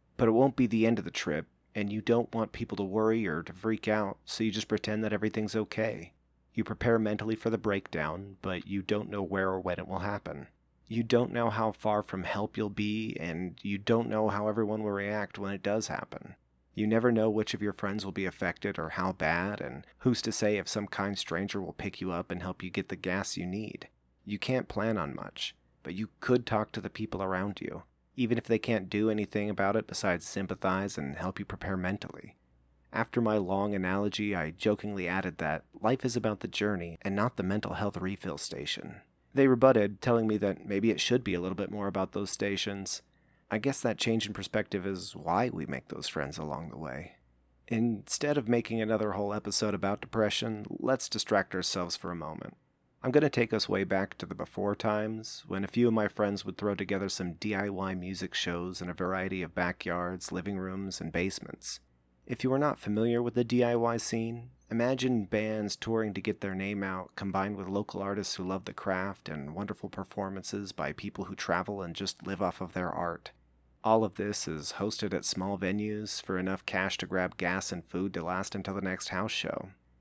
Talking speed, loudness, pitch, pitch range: 215 wpm, -32 LUFS, 100 Hz, 95-110 Hz